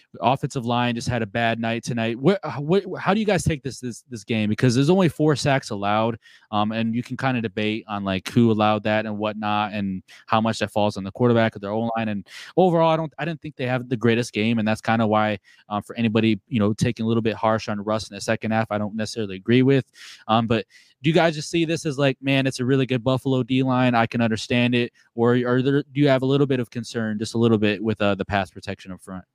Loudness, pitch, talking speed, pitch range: -22 LUFS, 115 Hz, 270 wpm, 110-130 Hz